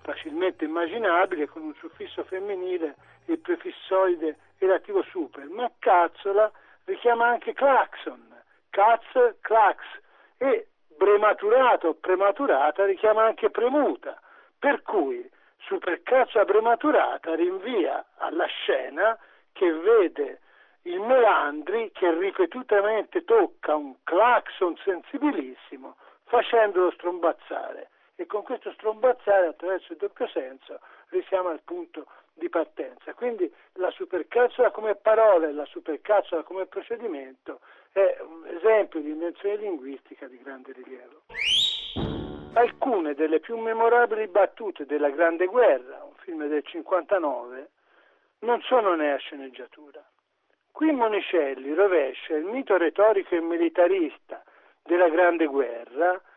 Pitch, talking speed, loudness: 220 Hz, 110 wpm, -24 LUFS